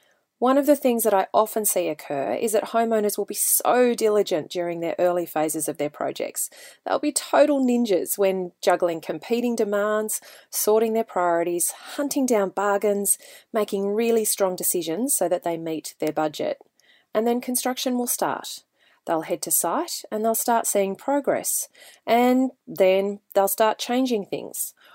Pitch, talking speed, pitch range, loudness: 210 Hz, 160 wpm, 180-240 Hz, -23 LUFS